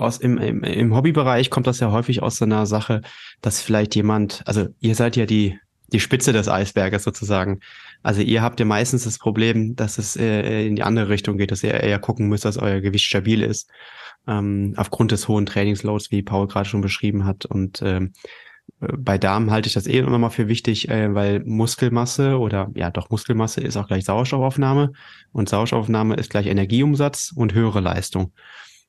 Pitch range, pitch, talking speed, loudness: 100-120 Hz, 110 Hz, 190 wpm, -20 LUFS